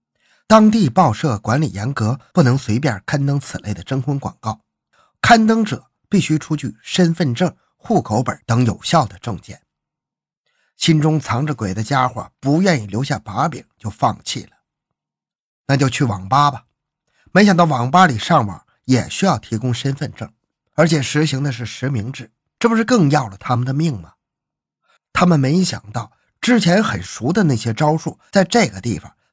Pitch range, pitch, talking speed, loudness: 120-170 Hz, 140 Hz, 245 characters per minute, -17 LUFS